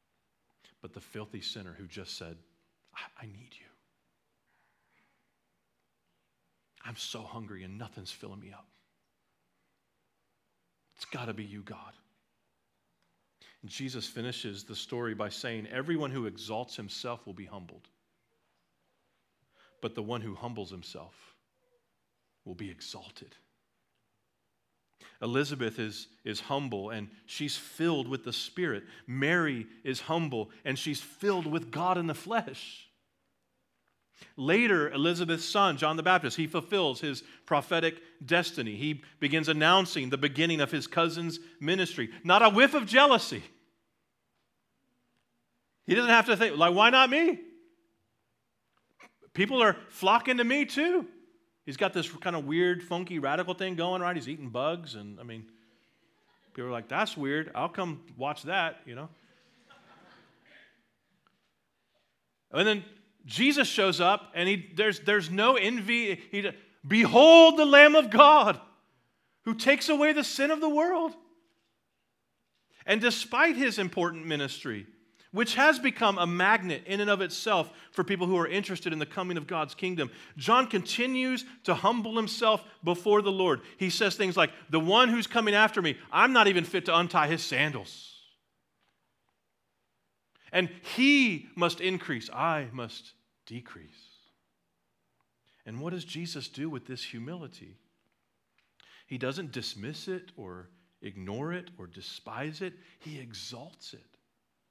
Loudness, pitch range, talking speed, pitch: -26 LUFS, 120-205 Hz, 140 wpm, 165 Hz